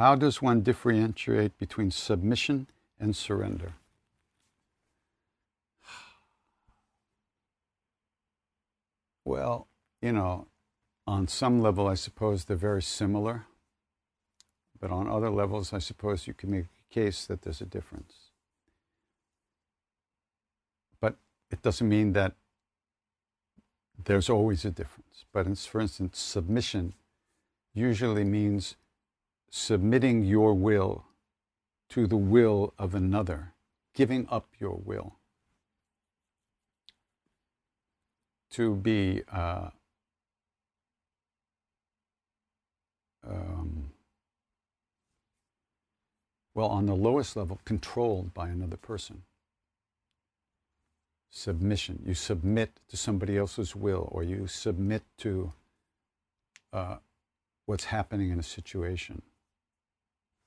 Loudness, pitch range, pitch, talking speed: -30 LUFS, 90-110 Hz, 100 Hz, 90 wpm